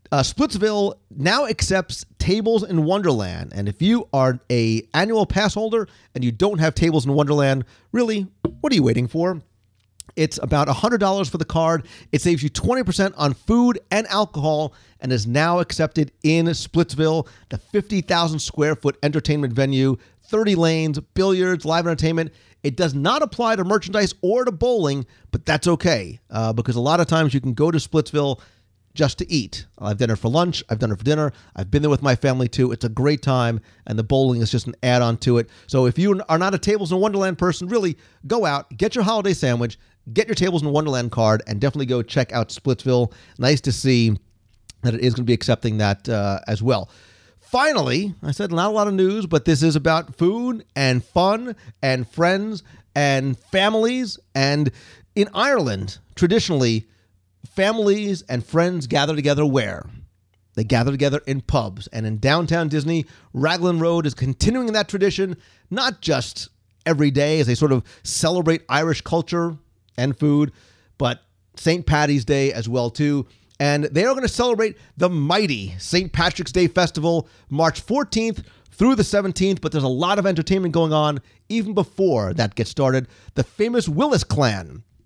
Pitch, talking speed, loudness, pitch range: 150 Hz, 185 wpm, -20 LUFS, 120-180 Hz